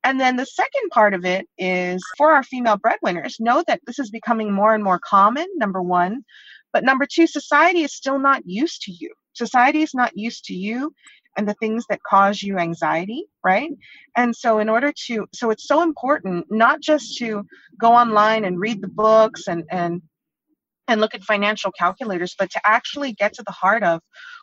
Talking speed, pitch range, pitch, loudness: 195 wpm, 195-280 Hz, 225 Hz, -19 LUFS